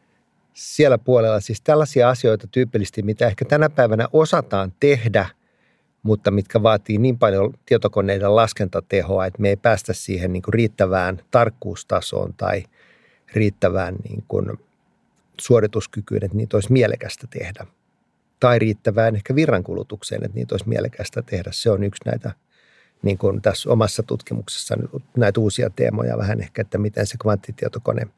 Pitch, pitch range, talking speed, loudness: 110 Hz, 100-120 Hz, 135 wpm, -20 LUFS